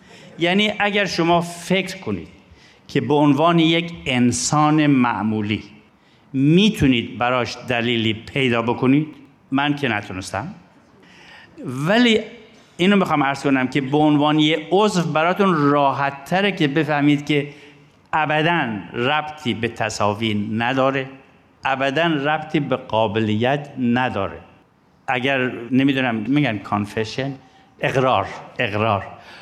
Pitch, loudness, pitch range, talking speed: 140 Hz, -19 LUFS, 120-155 Hz, 105 wpm